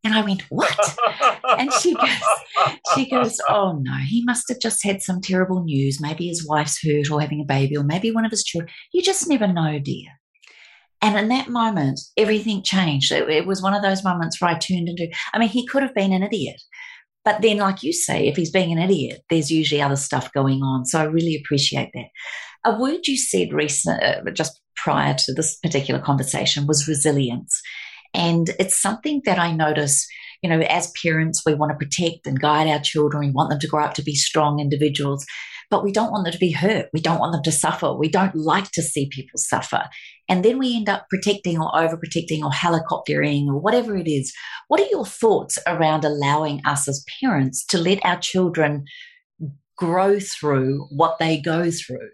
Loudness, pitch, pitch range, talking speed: -20 LUFS, 165 Hz, 150-205 Hz, 205 wpm